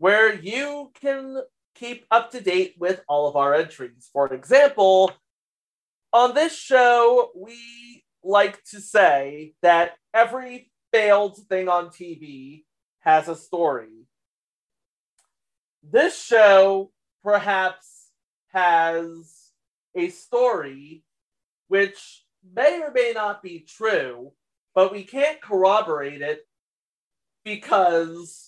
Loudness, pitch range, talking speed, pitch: -20 LUFS, 165-235 Hz, 105 wpm, 195 Hz